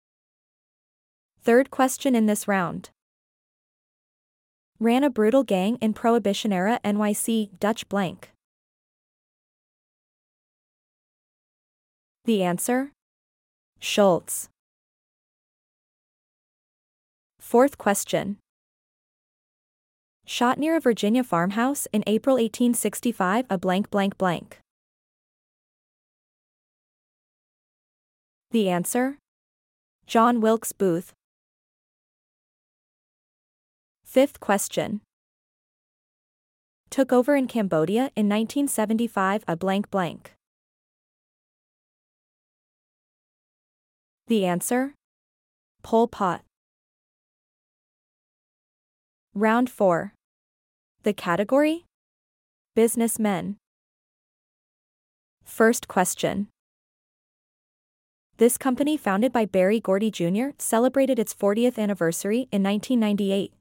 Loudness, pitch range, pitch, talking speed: -23 LUFS, 195-245 Hz, 215 Hz, 70 wpm